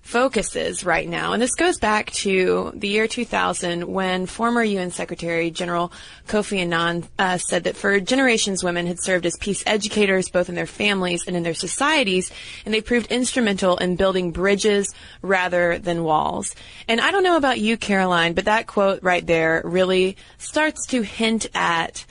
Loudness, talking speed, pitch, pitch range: -21 LUFS, 175 wpm, 190 Hz, 175-220 Hz